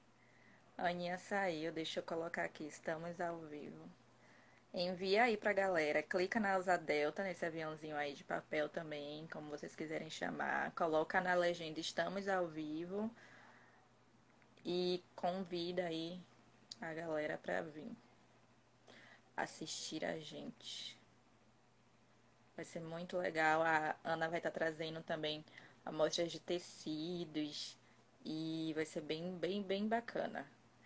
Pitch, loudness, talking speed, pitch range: 165 Hz, -41 LUFS, 125 wpm, 150-180 Hz